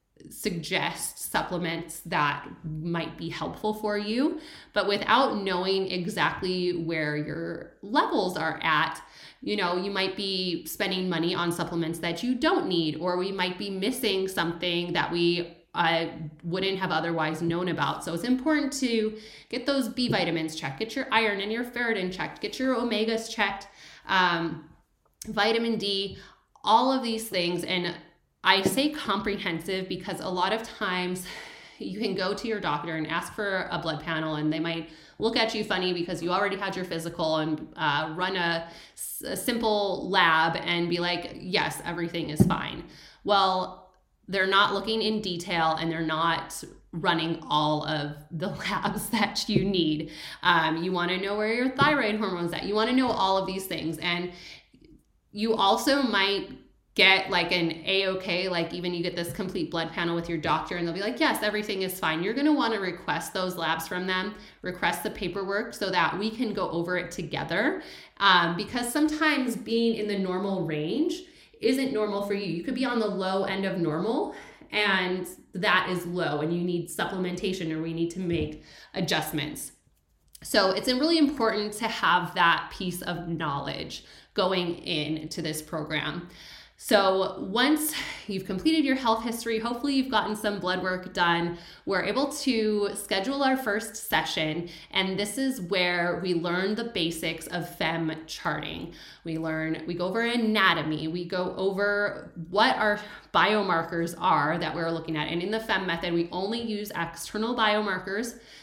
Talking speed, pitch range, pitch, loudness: 170 wpm, 170-210 Hz, 185 Hz, -27 LUFS